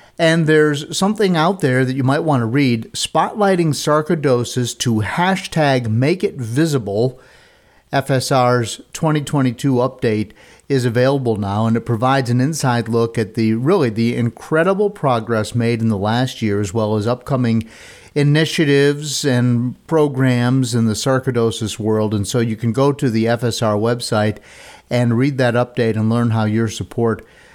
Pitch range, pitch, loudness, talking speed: 115-145 Hz, 125 Hz, -17 LUFS, 150 wpm